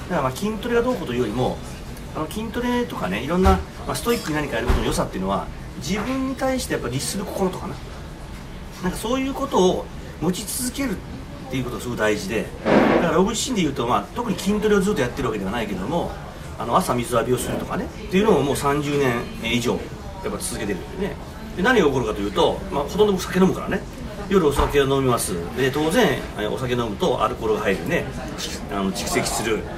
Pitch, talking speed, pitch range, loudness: 195 Hz, 445 characters per minute, 140-230 Hz, -22 LUFS